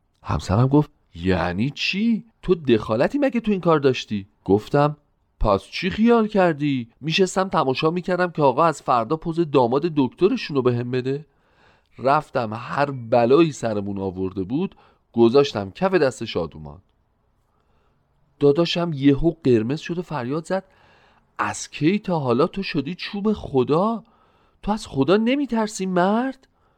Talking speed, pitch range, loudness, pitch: 135 wpm, 120-185 Hz, -21 LUFS, 145 Hz